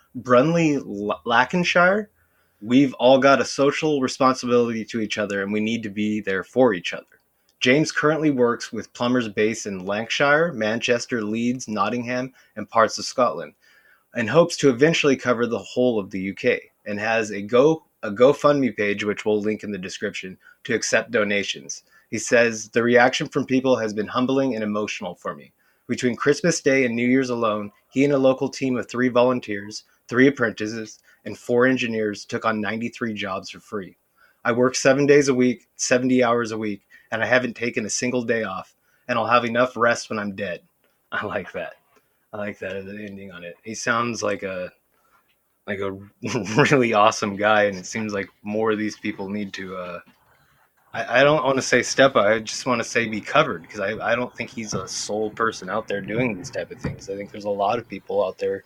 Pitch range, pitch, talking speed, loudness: 105-130 Hz, 115 Hz, 200 wpm, -22 LUFS